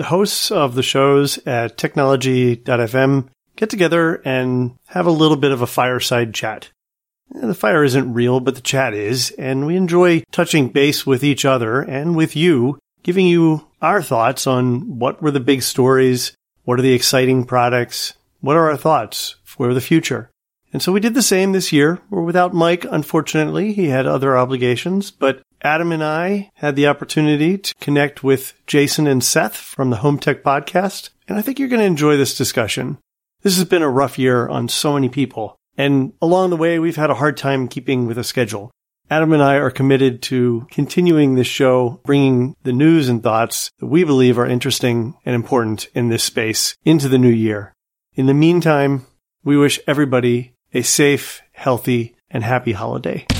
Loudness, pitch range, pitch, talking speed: -16 LUFS, 125-160 Hz, 135 Hz, 185 wpm